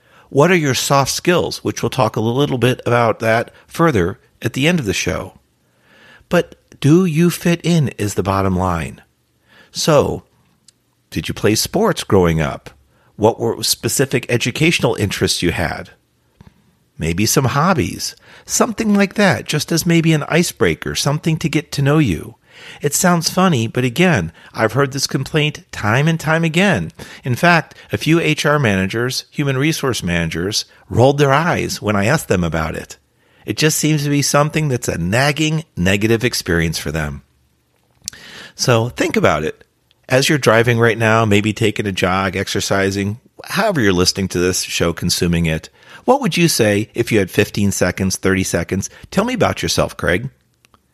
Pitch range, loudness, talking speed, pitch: 95-155 Hz, -16 LUFS, 165 wpm, 120 Hz